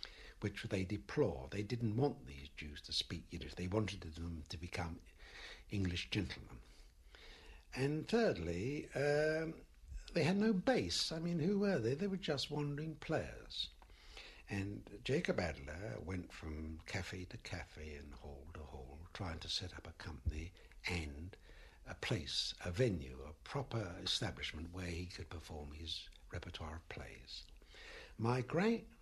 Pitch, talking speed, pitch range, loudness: 90 Hz, 145 wpm, 80-125 Hz, -41 LUFS